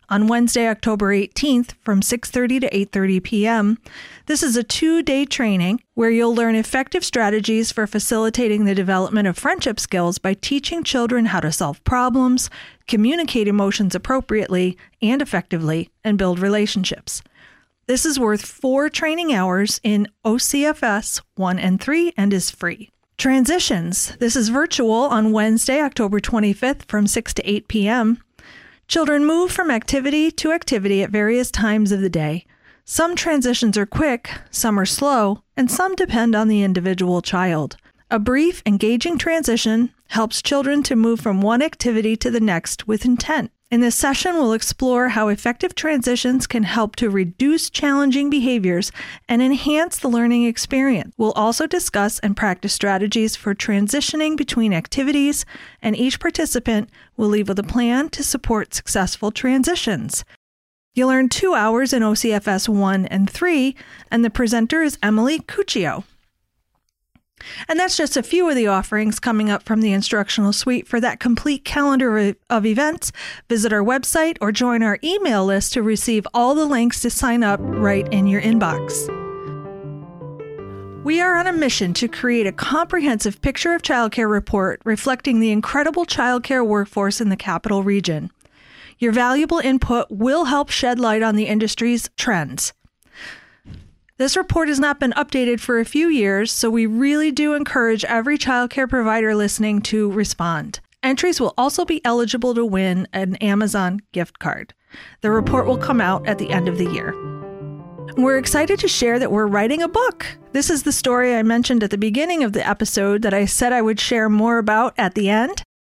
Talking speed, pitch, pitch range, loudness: 165 wpm, 230 Hz, 205-270 Hz, -19 LUFS